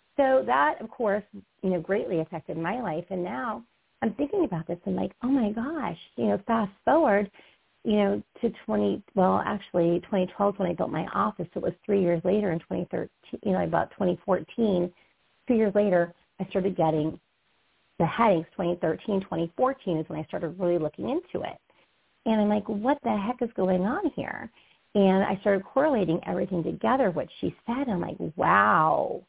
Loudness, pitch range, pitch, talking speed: -27 LUFS, 175-215 Hz, 195 Hz, 185 wpm